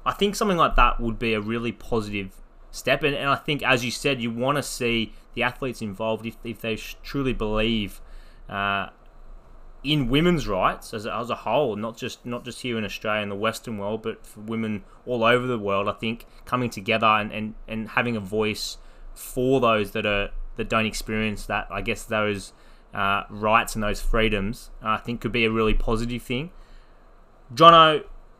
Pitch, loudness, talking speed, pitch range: 115 Hz, -24 LUFS, 190 wpm, 105-125 Hz